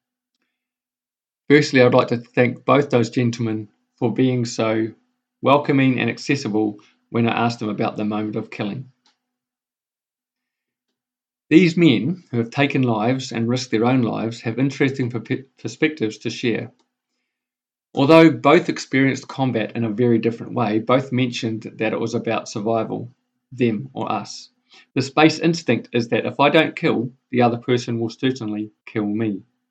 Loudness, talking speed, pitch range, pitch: -20 LUFS, 150 wpm, 115-140 Hz, 125 Hz